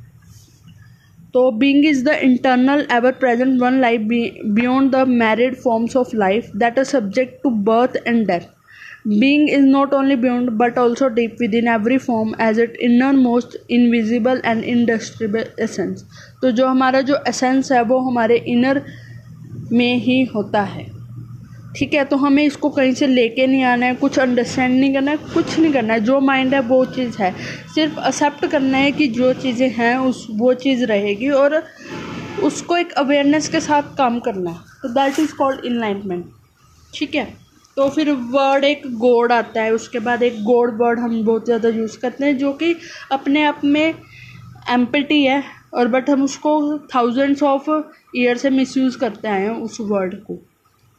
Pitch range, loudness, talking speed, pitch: 235-275 Hz, -17 LUFS, 175 wpm, 255 Hz